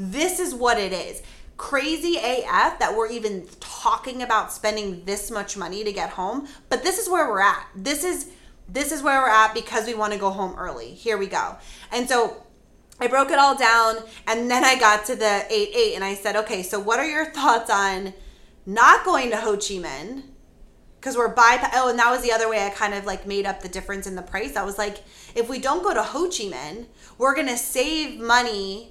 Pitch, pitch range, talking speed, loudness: 230 Hz, 205-270 Hz, 225 wpm, -22 LUFS